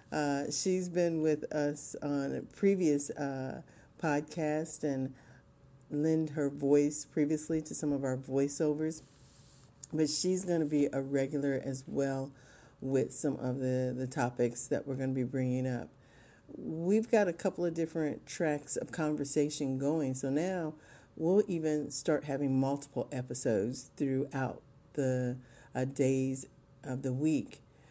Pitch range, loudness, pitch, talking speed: 135-155 Hz, -33 LUFS, 140 Hz, 145 wpm